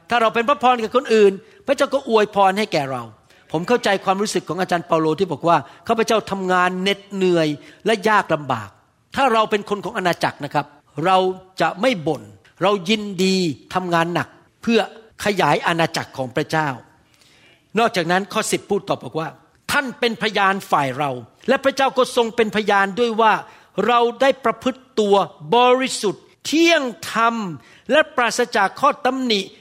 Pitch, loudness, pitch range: 195 Hz, -19 LUFS, 165-230 Hz